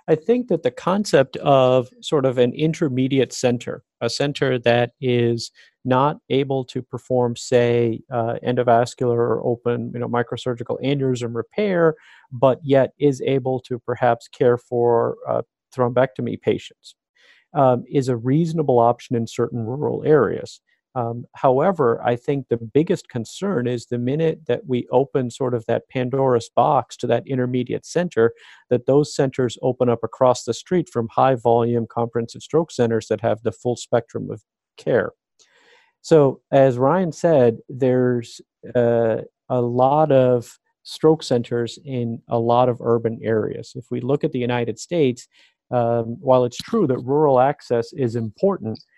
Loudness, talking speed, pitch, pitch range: -20 LUFS, 155 wpm, 125 Hz, 120-140 Hz